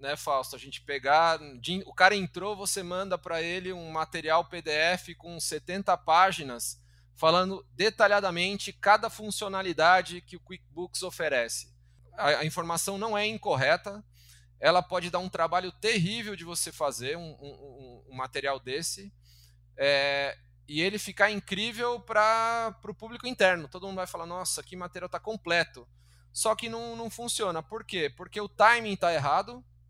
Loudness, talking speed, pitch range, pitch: -28 LUFS, 155 wpm, 140-200 Hz, 175 Hz